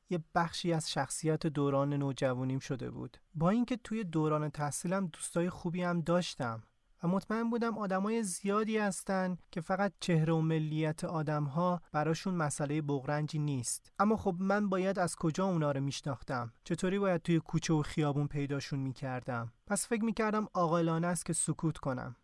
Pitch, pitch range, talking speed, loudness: 165 Hz, 145-190 Hz, 160 wpm, -34 LUFS